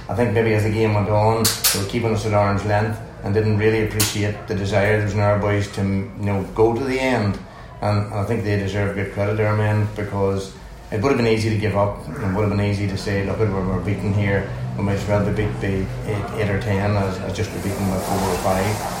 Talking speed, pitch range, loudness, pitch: 255 wpm, 100-110 Hz, -21 LUFS, 105 Hz